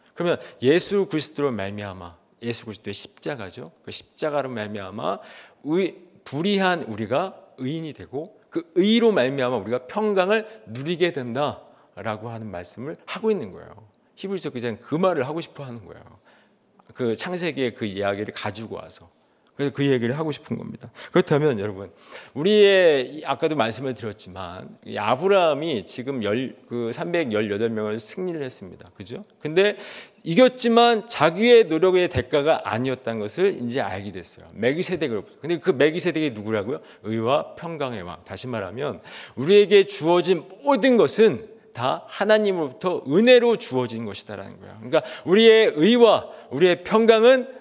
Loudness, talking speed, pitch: -22 LUFS, 340 characters per minute, 150 Hz